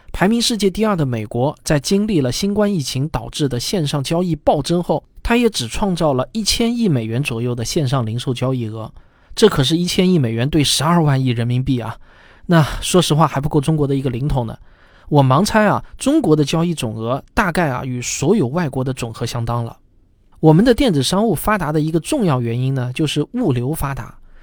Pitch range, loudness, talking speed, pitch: 125-175 Hz, -17 LUFS, 315 characters per minute, 145 Hz